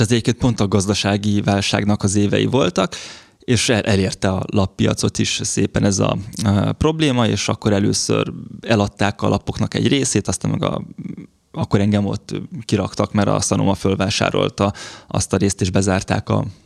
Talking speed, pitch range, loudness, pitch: 155 wpm, 100-115 Hz, -18 LUFS, 105 Hz